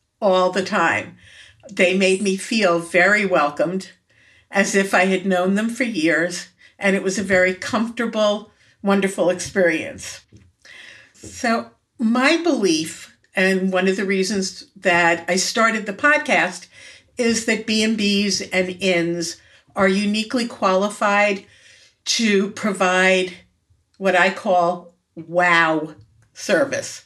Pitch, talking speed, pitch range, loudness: 190 Hz, 120 wpm, 175-205 Hz, -19 LUFS